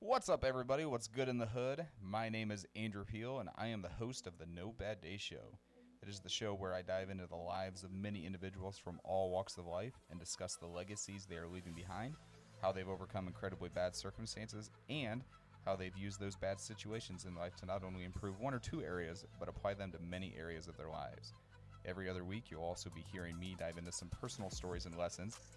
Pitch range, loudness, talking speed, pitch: 90-110 Hz, -45 LUFS, 230 wpm, 95 Hz